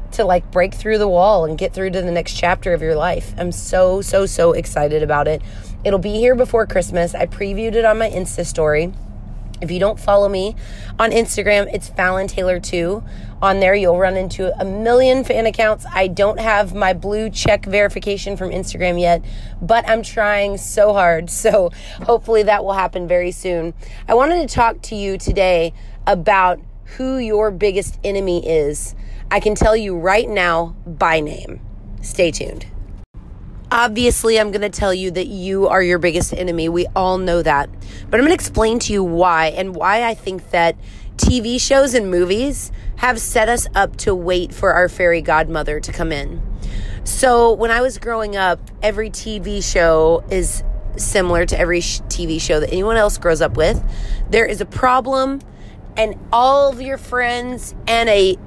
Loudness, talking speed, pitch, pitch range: -17 LUFS, 185 wpm, 190 Hz, 170-220 Hz